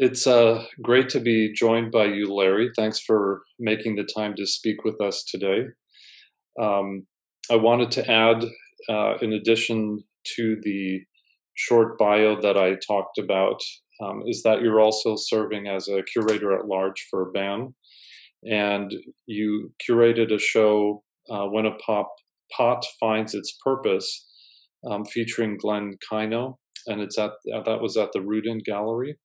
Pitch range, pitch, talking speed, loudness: 105-115 Hz, 110 Hz, 150 wpm, -23 LUFS